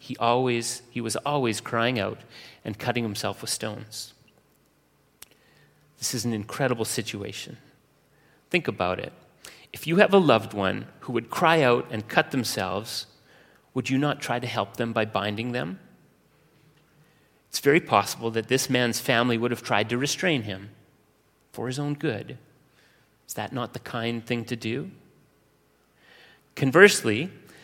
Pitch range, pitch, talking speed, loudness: 110-135 Hz, 120 Hz, 150 wpm, -25 LUFS